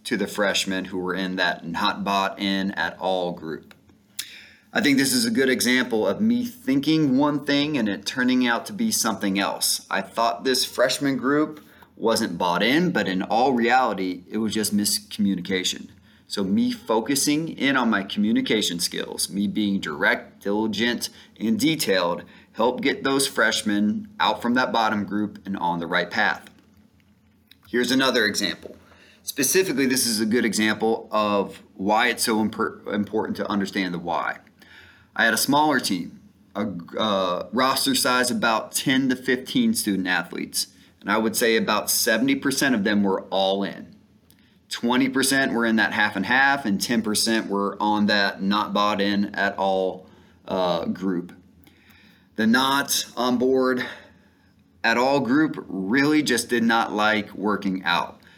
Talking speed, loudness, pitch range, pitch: 160 wpm, -22 LUFS, 100-135 Hz, 110 Hz